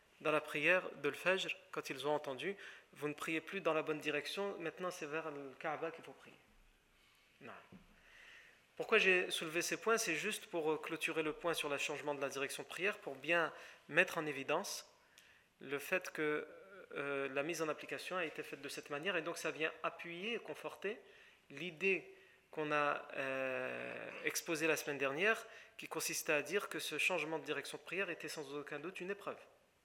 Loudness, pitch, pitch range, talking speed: -39 LUFS, 160 Hz, 150-185 Hz, 195 wpm